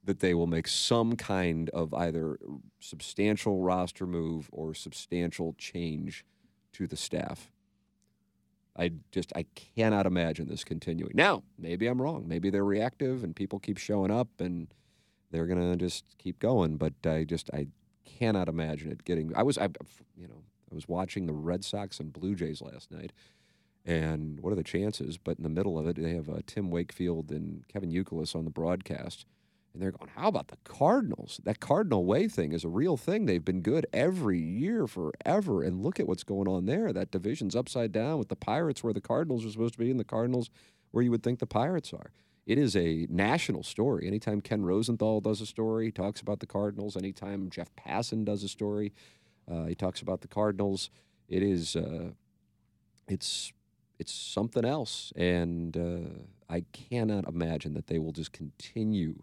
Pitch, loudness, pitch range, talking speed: 95 Hz, -32 LUFS, 85-105 Hz, 190 wpm